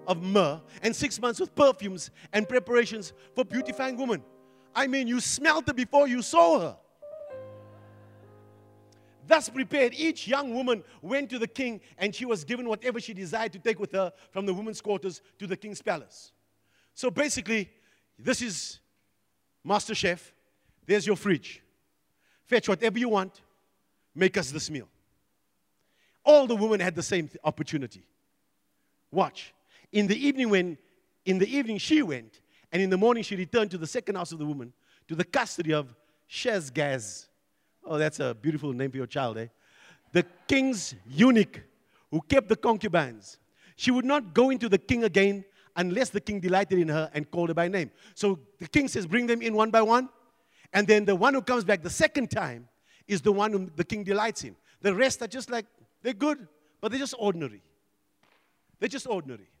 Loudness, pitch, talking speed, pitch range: -27 LUFS, 195 Hz, 180 wpm, 150-240 Hz